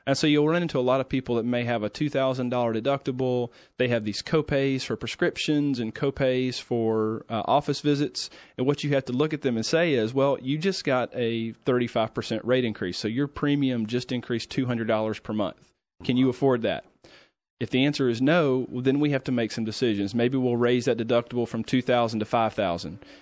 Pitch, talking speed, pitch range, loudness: 125 Hz, 225 wpm, 115-135 Hz, -26 LUFS